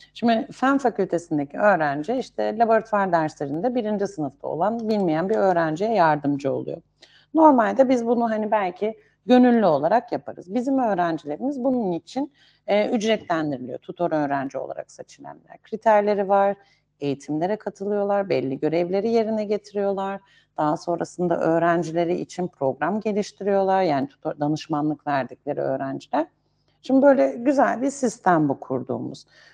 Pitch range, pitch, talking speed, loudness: 155-225 Hz, 195 Hz, 120 wpm, -23 LUFS